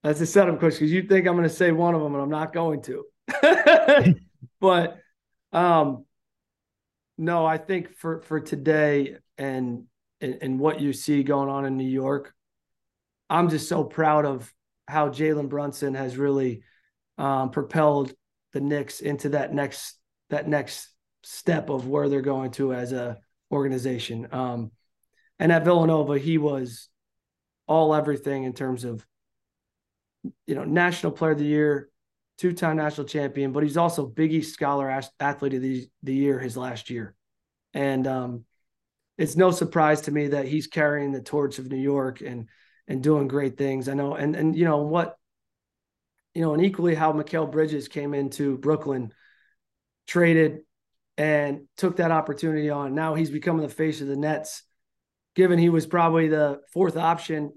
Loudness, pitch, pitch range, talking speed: -24 LUFS, 145 Hz, 135-160 Hz, 165 wpm